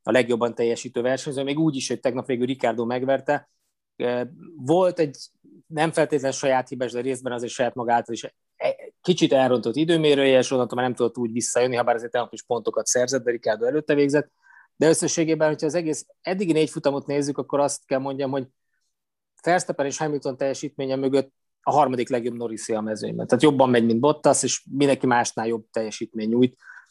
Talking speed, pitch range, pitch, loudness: 180 wpm, 120-150 Hz, 135 Hz, -23 LUFS